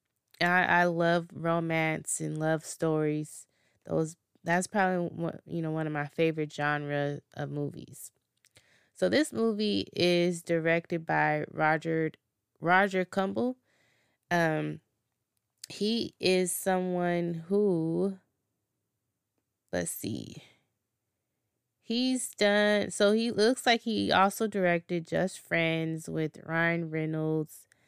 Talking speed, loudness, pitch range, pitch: 110 wpm, -29 LUFS, 155-185 Hz, 165 Hz